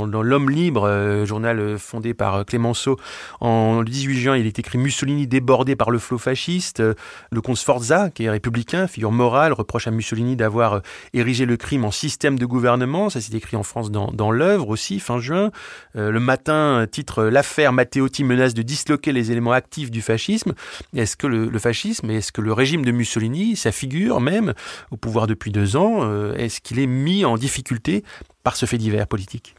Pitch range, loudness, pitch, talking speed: 110-135 Hz, -20 LUFS, 120 Hz, 185 wpm